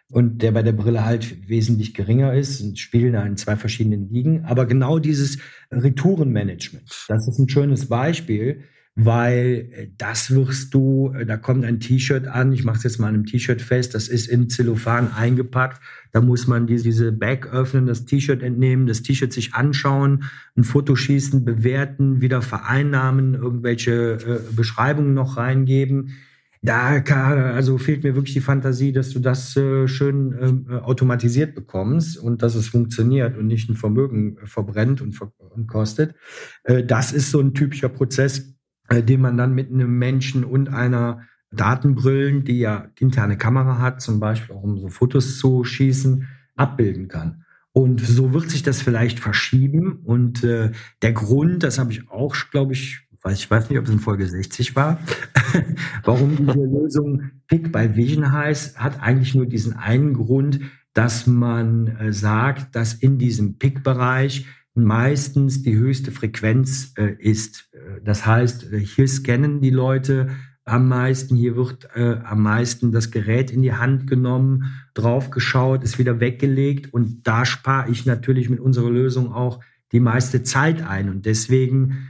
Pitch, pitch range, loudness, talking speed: 125 Hz, 115-135 Hz, -19 LUFS, 160 wpm